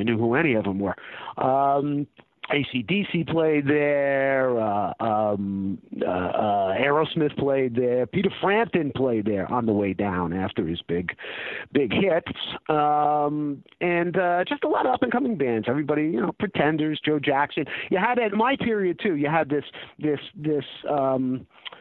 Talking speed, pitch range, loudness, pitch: 160 wpm, 125-165 Hz, -24 LUFS, 145 Hz